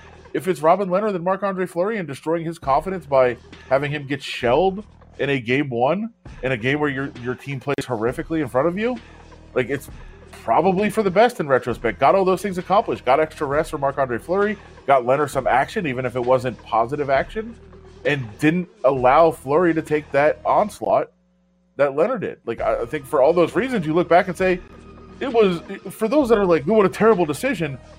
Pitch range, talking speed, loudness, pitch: 130-185 Hz, 210 wpm, -20 LUFS, 155 Hz